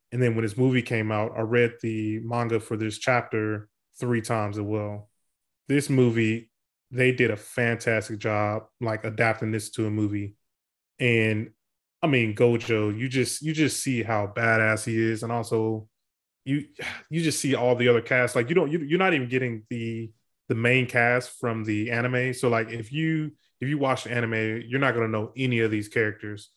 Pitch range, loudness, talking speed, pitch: 110-125 Hz, -25 LUFS, 195 wpm, 115 Hz